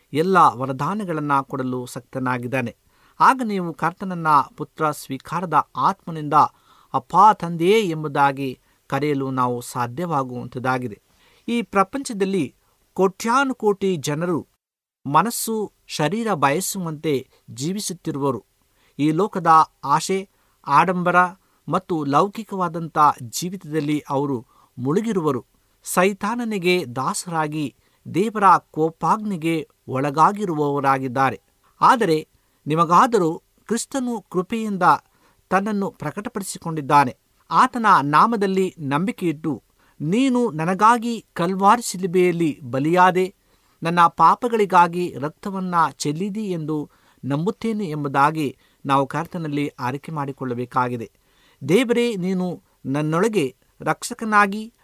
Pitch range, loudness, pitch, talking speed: 140-195 Hz, -21 LUFS, 165 Hz, 75 wpm